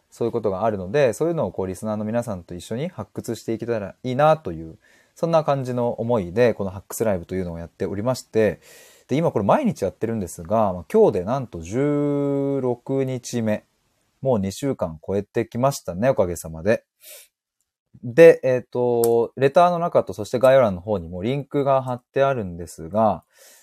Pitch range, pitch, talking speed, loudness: 100-135 Hz, 115 Hz, 375 characters per minute, -22 LUFS